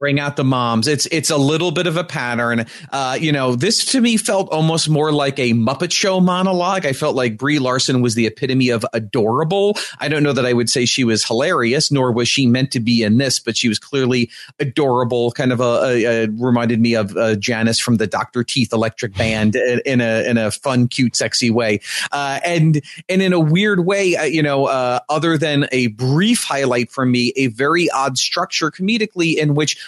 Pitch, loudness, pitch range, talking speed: 130 Hz, -17 LUFS, 120-155 Hz, 215 wpm